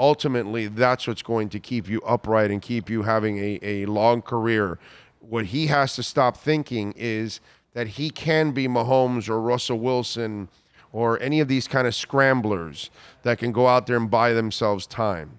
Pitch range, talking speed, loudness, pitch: 110-125 Hz, 185 wpm, -23 LUFS, 115 Hz